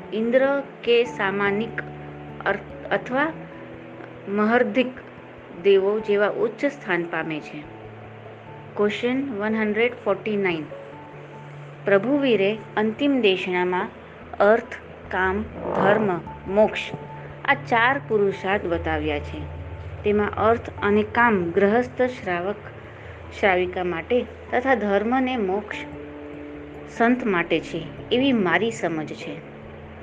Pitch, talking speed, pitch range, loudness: 195 Hz, 90 wpm, 145-220 Hz, -23 LUFS